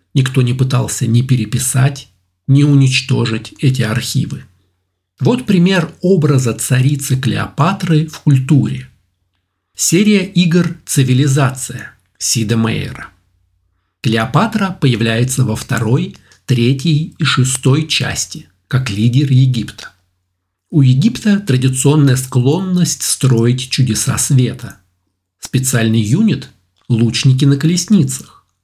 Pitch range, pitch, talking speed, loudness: 115-145 Hz, 130 Hz, 90 wpm, -14 LUFS